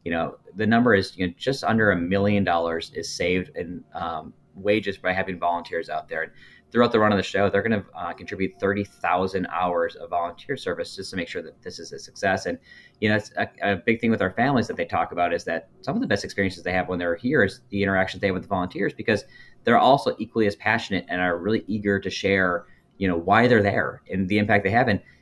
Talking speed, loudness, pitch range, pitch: 255 wpm, -24 LUFS, 90-105 Hz, 100 Hz